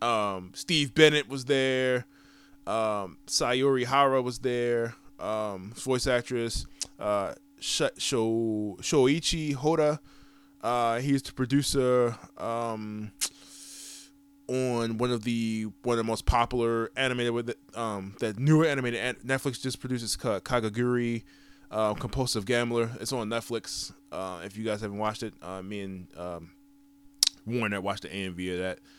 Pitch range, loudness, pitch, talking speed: 110-140 Hz, -29 LUFS, 120 Hz, 135 wpm